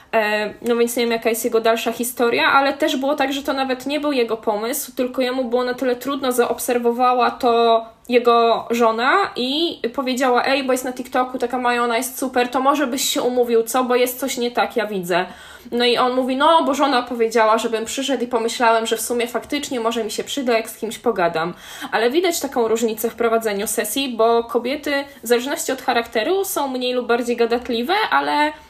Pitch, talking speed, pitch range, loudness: 245 Hz, 205 wpm, 230-270 Hz, -19 LUFS